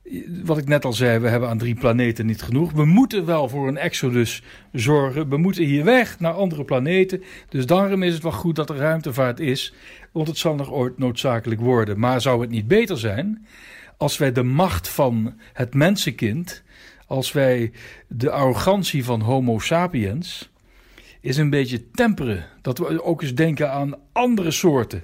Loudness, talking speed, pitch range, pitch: -21 LUFS, 180 wpm, 125-170 Hz, 140 Hz